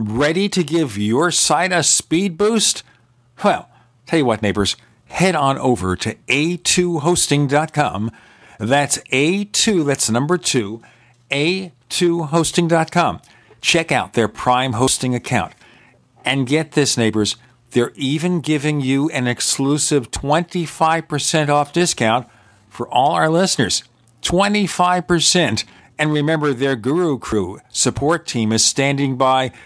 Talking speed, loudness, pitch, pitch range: 115 wpm, -17 LUFS, 140 Hz, 120-165 Hz